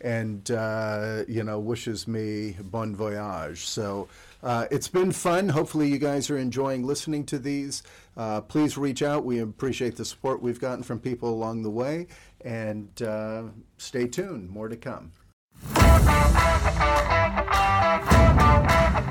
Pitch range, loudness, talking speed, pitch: 105-135 Hz, -25 LUFS, 135 wpm, 115 Hz